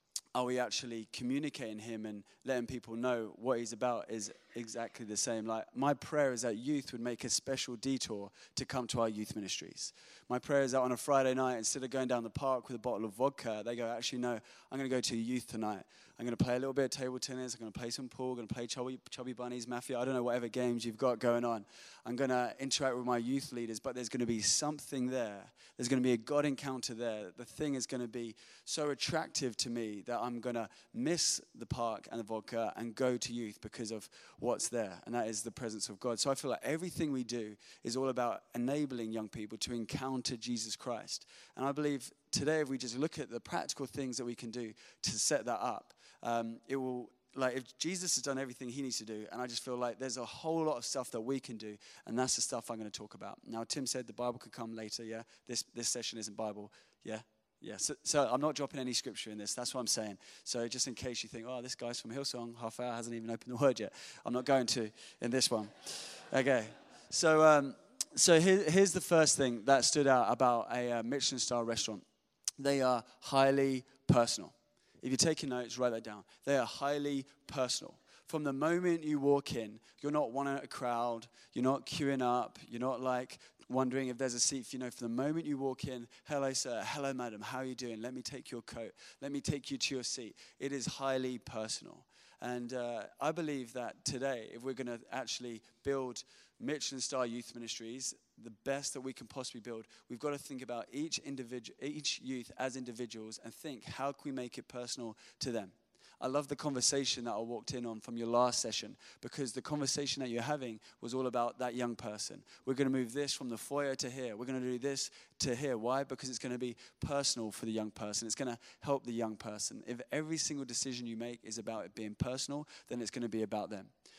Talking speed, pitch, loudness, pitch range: 240 wpm, 125 Hz, -37 LUFS, 115-135 Hz